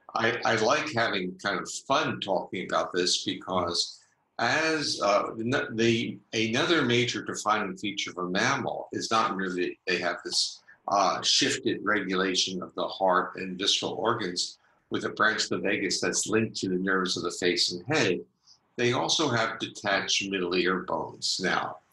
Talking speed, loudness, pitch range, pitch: 165 wpm, -27 LUFS, 90-115 Hz, 95 Hz